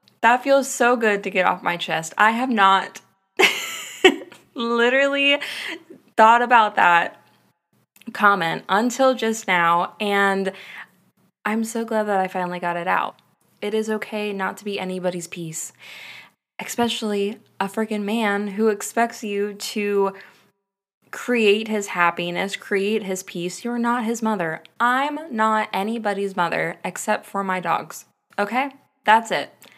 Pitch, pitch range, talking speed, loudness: 210 Hz, 195-235 Hz, 135 wpm, -21 LUFS